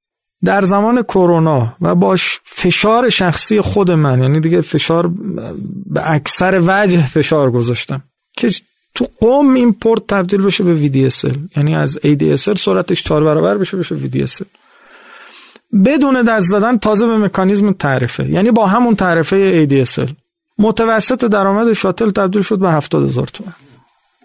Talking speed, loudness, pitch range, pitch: 140 wpm, -13 LUFS, 155-220 Hz, 190 Hz